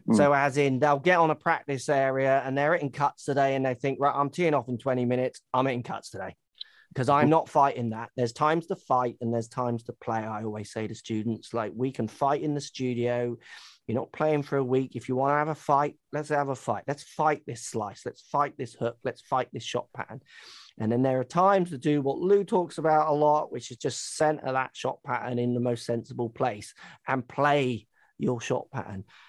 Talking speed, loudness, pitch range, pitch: 235 wpm, -27 LUFS, 120-145 Hz, 135 Hz